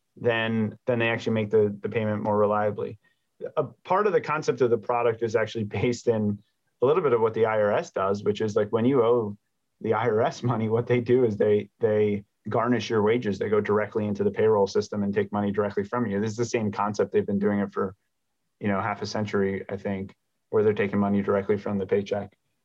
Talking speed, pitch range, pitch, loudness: 230 wpm, 105-120 Hz, 110 Hz, -25 LUFS